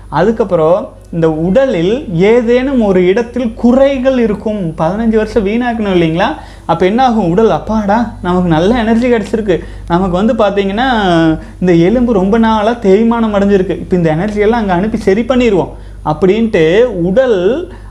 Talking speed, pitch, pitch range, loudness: 130 wpm, 210 Hz, 180-235 Hz, -11 LUFS